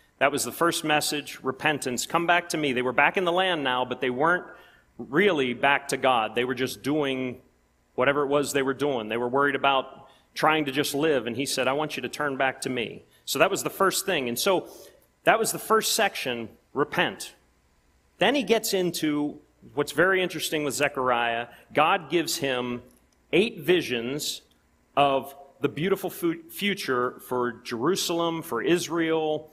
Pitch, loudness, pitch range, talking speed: 140 Hz, -25 LUFS, 125-165 Hz, 180 wpm